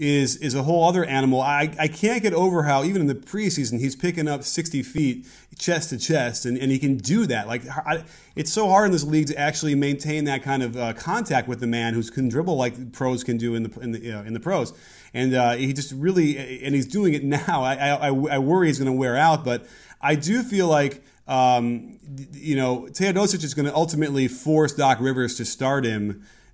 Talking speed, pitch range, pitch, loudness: 235 wpm, 125-155 Hz, 140 Hz, -23 LUFS